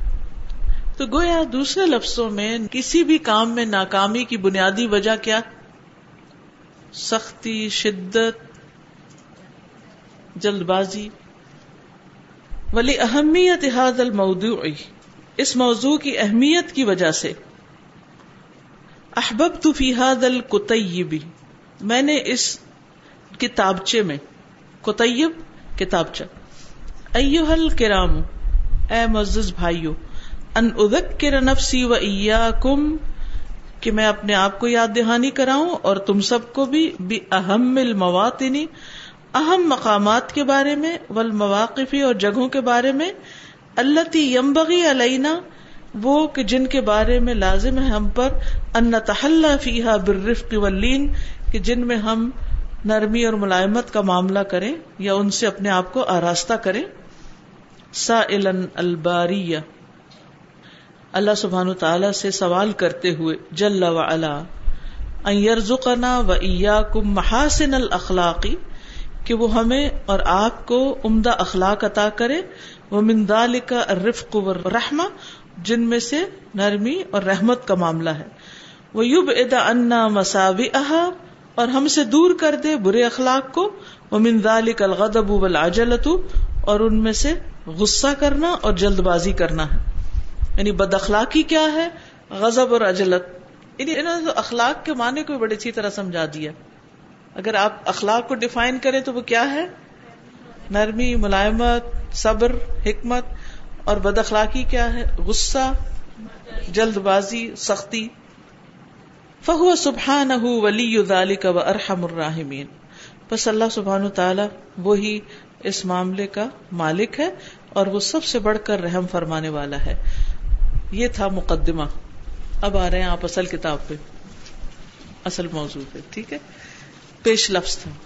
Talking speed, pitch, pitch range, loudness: 120 wpm, 220 Hz, 190-255 Hz, -20 LUFS